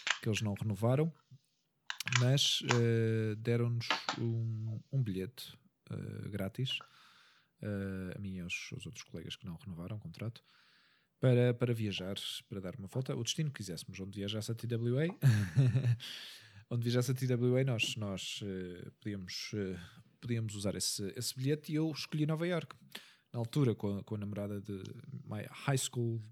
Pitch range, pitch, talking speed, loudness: 100-130 Hz, 115 Hz, 155 wpm, -36 LUFS